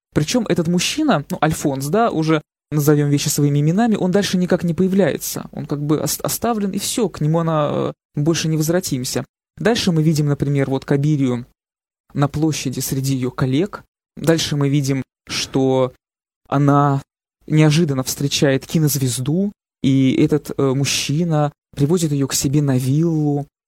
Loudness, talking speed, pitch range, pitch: -18 LUFS, 140 wpm, 140-170 Hz, 150 Hz